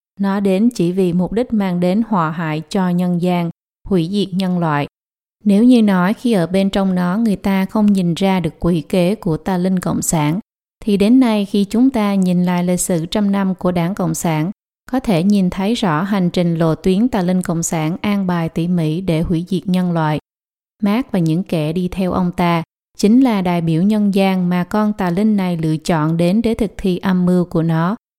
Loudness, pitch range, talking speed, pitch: -16 LUFS, 170-205 Hz, 225 wpm, 185 Hz